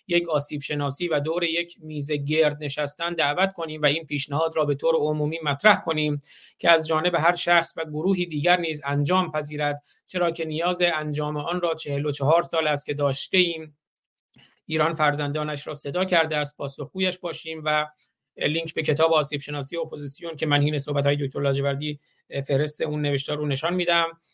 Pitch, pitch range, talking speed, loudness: 155 Hz, 145-165 Hz, 180 wpm, -24 LUFS